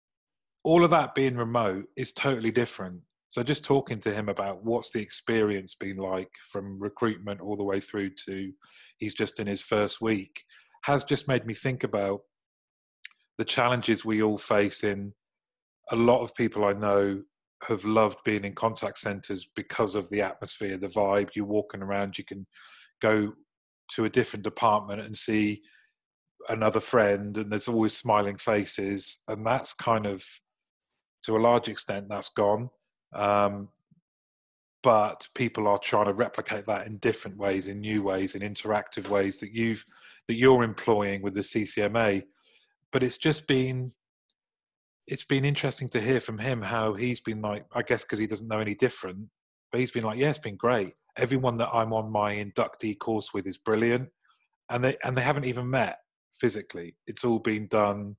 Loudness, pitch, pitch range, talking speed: -28 LUFS, 110 Hz, 100-120 Hz, 175 wpm